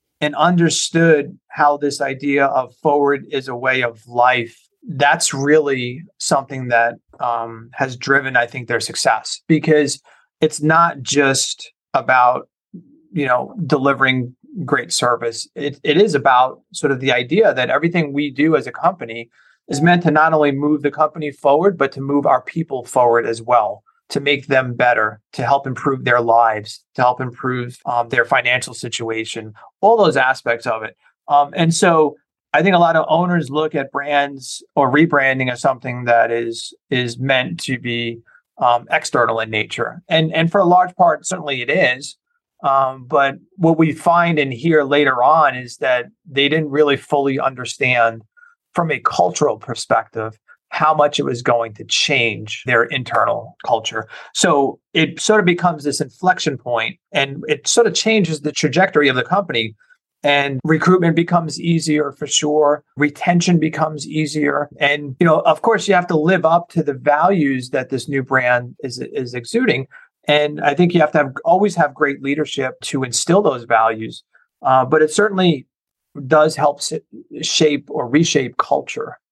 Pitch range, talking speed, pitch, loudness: 125-160 Hz, 170 wpm, 145 Hz, -17 LUFS